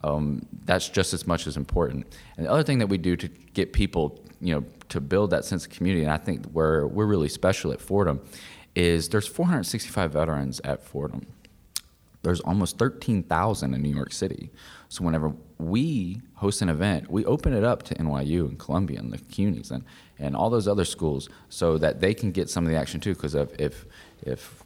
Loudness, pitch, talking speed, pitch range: -26 LUFS, 85 Hz, 200 wpm, 75-100 Hz